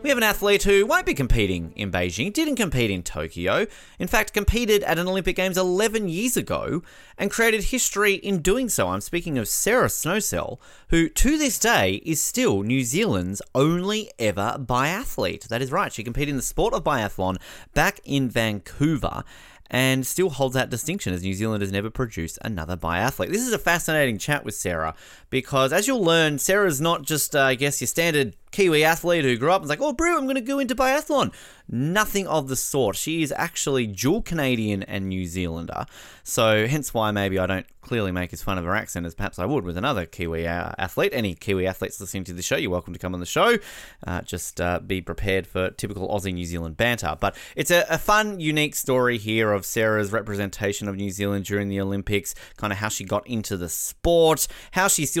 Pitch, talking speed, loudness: 125 Hz, 210 wpm, -23 LUFS